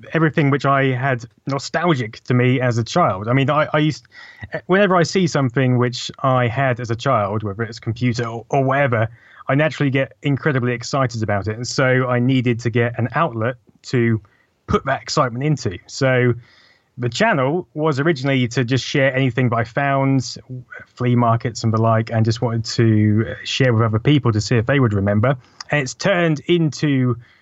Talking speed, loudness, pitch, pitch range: 190 wpm, -19 LUFS, 125 Hz, 115-140 Hz